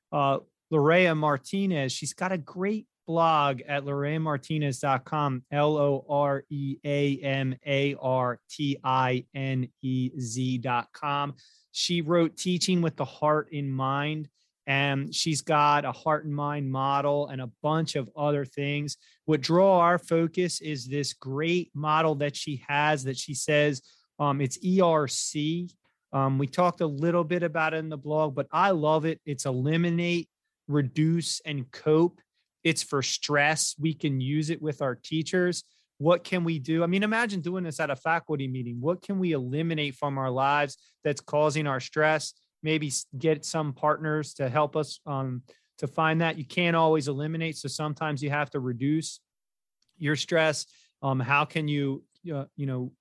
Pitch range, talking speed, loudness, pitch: 140-160 Hz, 165 wpm, -27 LUFS, 150 Hz